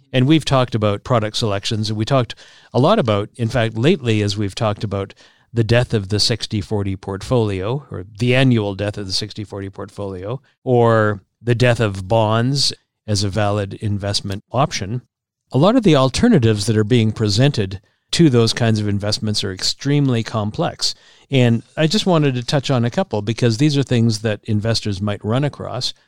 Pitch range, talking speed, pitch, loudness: 105-125 Hz, 180 wpm, 115 Hz, -18 LUFS